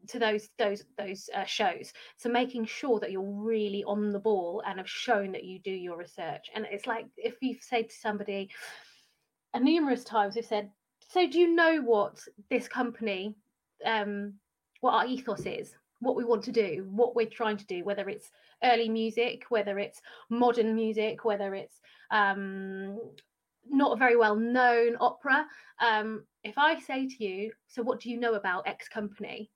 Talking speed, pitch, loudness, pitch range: 180 wpm, 220 Hz, -30 LUFS, 205-240 Hz